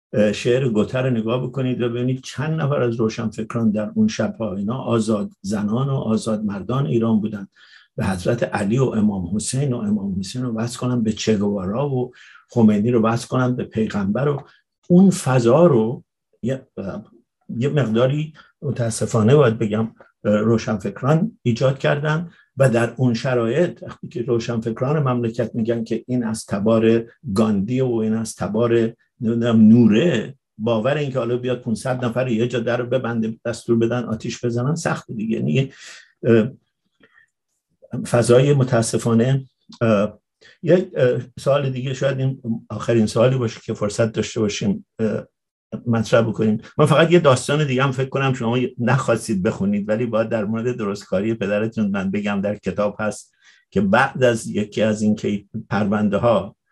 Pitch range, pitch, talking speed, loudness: 110-130 Hz, 115 Hz, 150 wpm, -20 LUFS